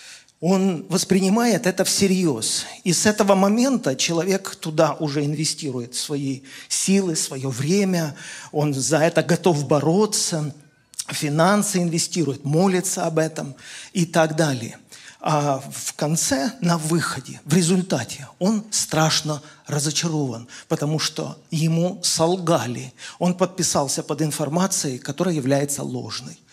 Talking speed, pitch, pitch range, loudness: 115 wpm, 165 Hz, 150-185 Hz, -21 LUFS